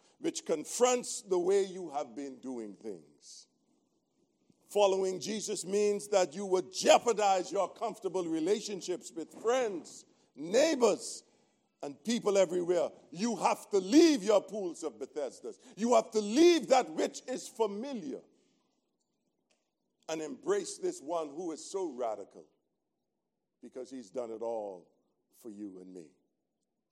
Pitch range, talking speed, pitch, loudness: 180-280 Hz, 130 wpm, 205 Hz, -31 LUFS